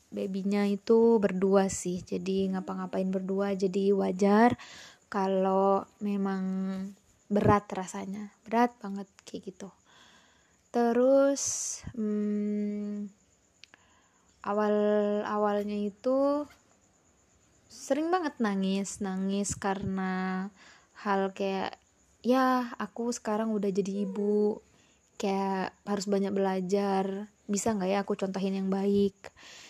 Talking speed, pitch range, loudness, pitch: 95 wpm, 195-210 Hz, -29 LUFS, 200 Hz